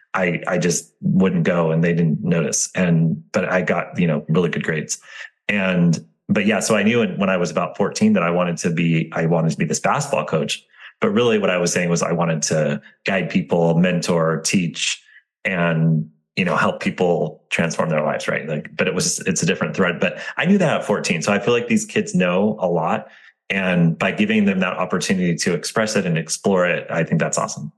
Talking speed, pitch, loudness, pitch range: 225 wpm, 85 Hz, -19 LUFS, 85-100 Hz